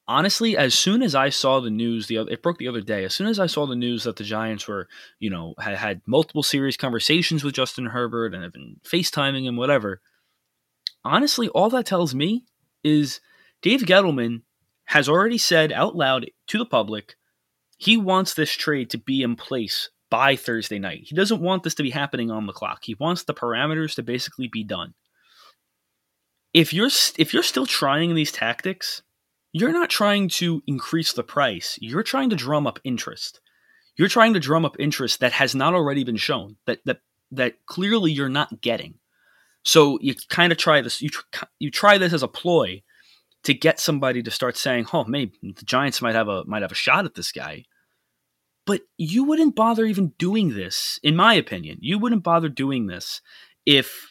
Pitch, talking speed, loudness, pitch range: 145 Hz, 195 wpm, -21 LUFS, 120-180 Hz